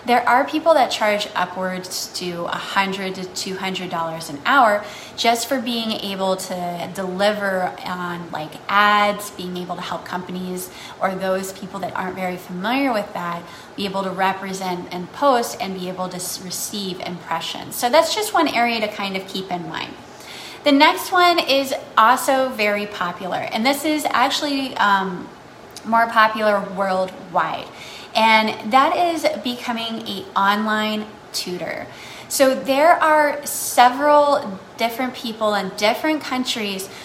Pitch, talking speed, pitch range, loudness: 205 Hz, 145 wpm, 185-255 Hz, -20 LUFS